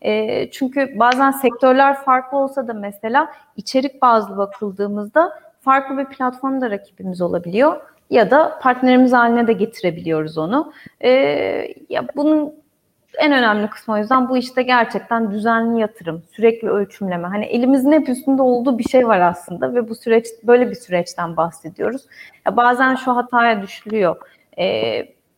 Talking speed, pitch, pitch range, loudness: 135 wpm, 245 Hz, 210-270 Hz, -17 LUFS